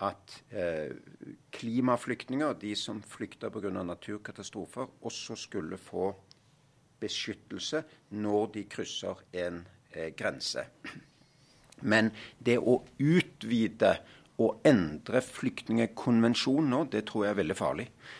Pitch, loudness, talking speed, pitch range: 115 Hz, -32 LUFS, 105 wpm, 105-125 Hz